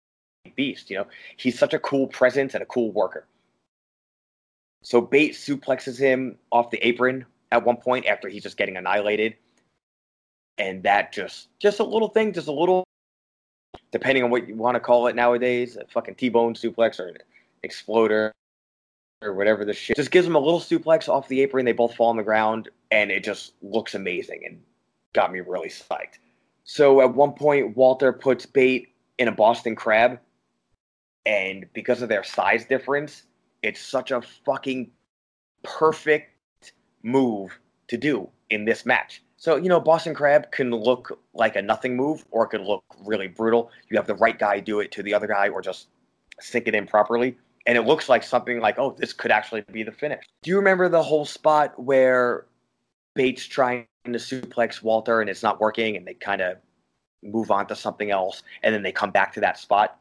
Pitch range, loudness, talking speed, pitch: 110-140 Hz, -23 LUFS, 190 wpm, 125 Hz